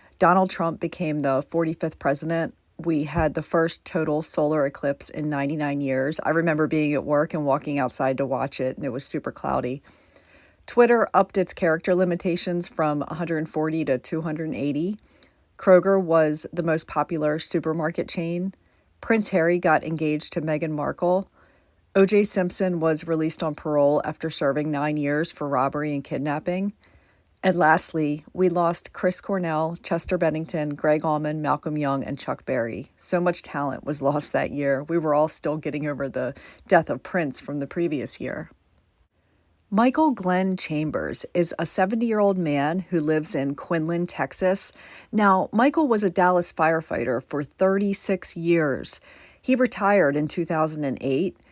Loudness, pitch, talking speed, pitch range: -24 LUFS, 160 Hz, 155 wpm, 145-180 Hz